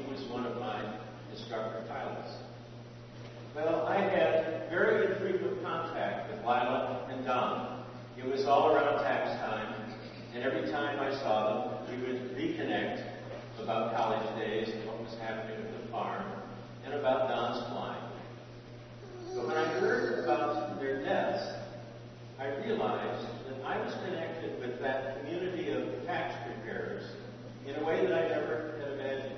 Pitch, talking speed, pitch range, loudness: 120 Hz, 140 wpm, 115-135 Hz, -34 LUFS